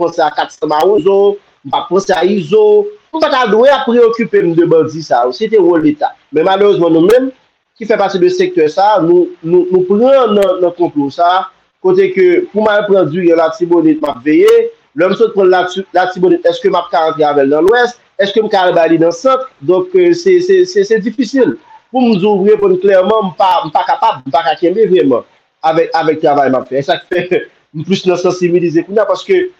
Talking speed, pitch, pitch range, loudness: 215 wpm, 200 Hz, 175-275 Hz, -11 LUFS